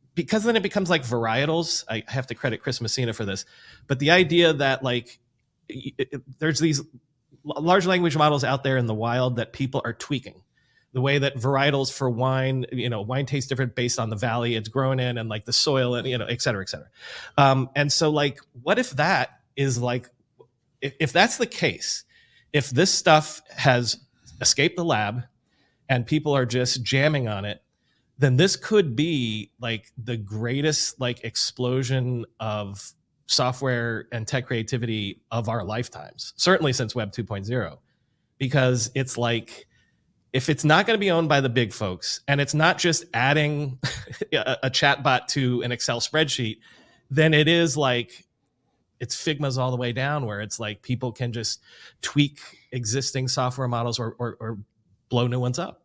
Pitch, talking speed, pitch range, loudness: 130 Hz, 180 wpm, 120-145 Hz, -24 LUFS